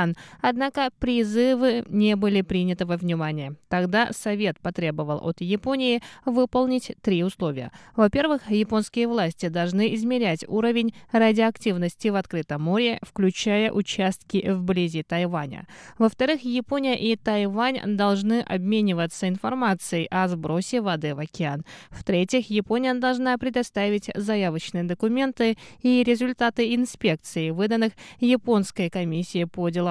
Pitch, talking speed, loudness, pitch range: 210 Hz, 110 wpm, -24 LUFS, 175-235 Hz